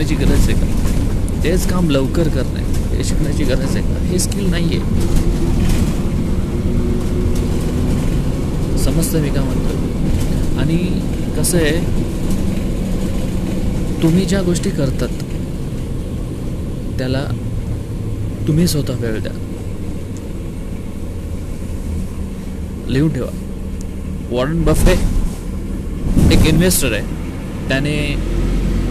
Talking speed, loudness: 85 wpm, -19 LUFS